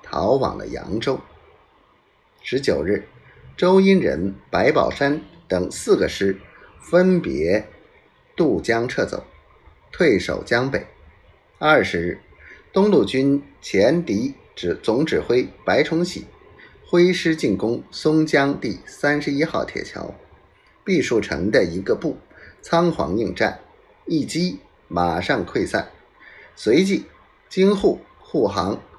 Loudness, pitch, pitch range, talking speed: -21 LUFS, 165 Hz, 140-195 Hz, 165 characters per minute